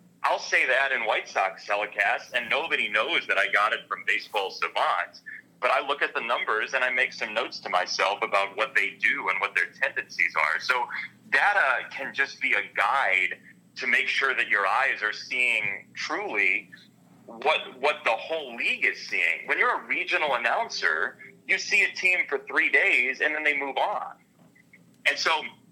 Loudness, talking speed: -24 LUFS, 190 wpm